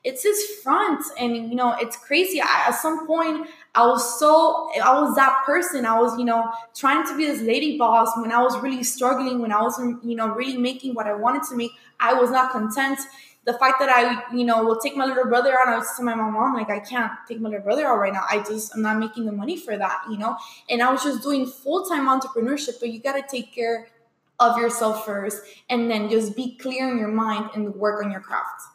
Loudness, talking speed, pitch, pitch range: -22 LUFS, 245 wpm, 245 Hz, 225-270 Hz